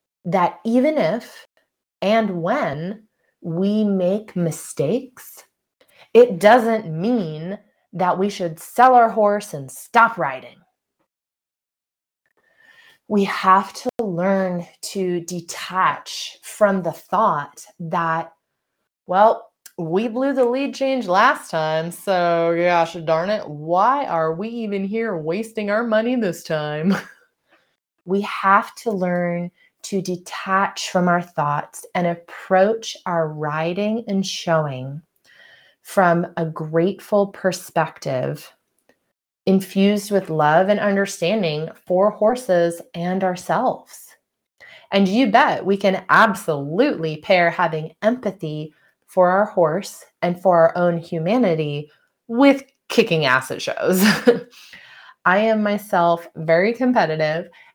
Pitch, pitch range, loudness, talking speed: 190 Hz, 170-215 Hz, -20 LUFS, 110 wpm